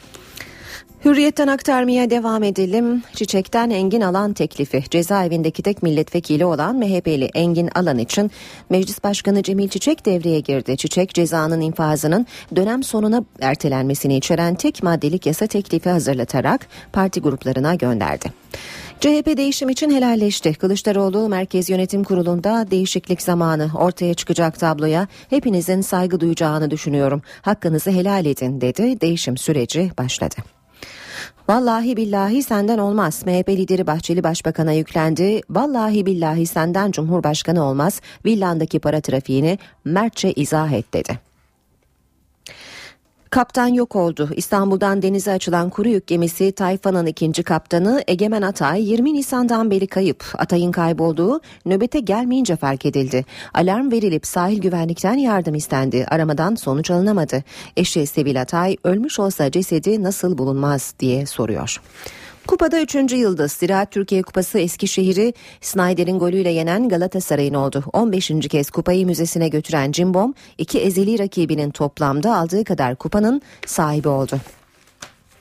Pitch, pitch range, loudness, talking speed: 180 Hz, 155-200 Hz, -19 LUFS, 120 wpm